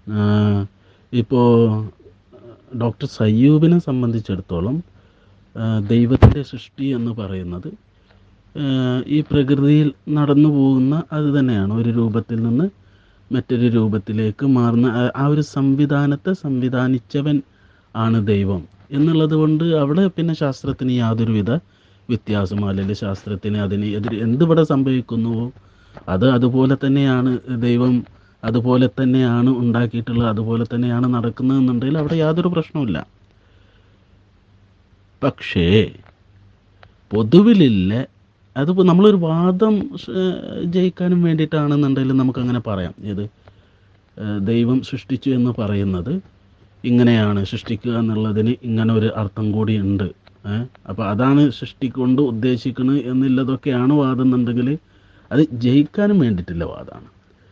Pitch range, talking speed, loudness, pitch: 100-135 Hz, 90 wpm, -18 LUFS, 120 Hz